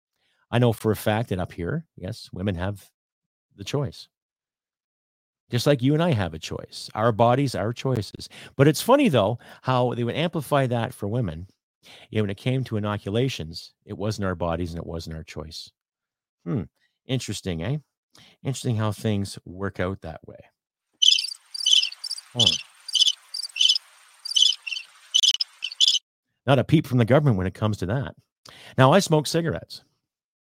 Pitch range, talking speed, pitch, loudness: 95-130 Hz, 155 wpm, 115 Hz, -23 LUFS